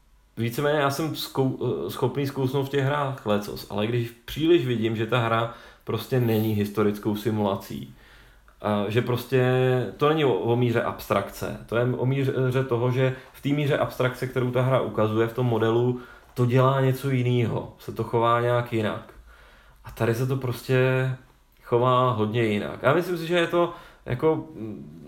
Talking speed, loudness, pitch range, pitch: 165 wpm, -25 LUFS, 115-135 Hz, 125 Hz